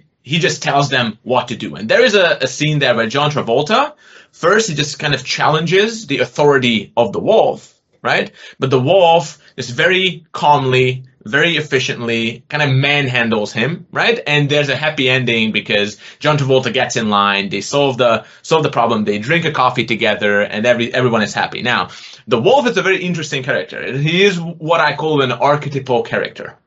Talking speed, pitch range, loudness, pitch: 190 wpm, 120-155 Hz, -15 LUFS, 140 Hz